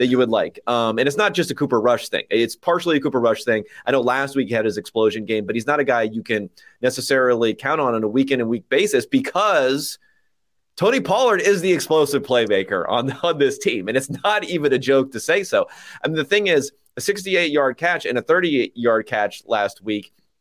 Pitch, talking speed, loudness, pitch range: 135 Hz, 235 wpm, -20 LUFS, 115-170 Hz